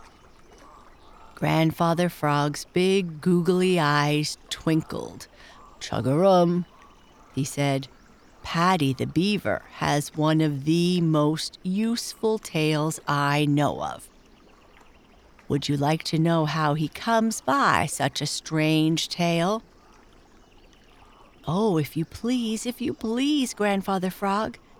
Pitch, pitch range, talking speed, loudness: 160 Hz, 150-190 Hz, 105 wpm, -24 LUFS